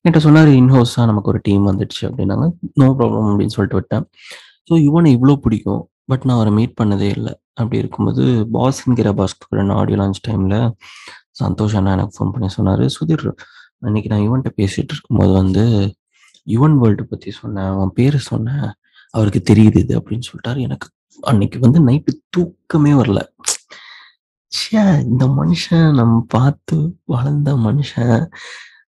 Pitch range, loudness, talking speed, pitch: 105-140 Hz, -15 LUFS, 145 wpm, 115 Hz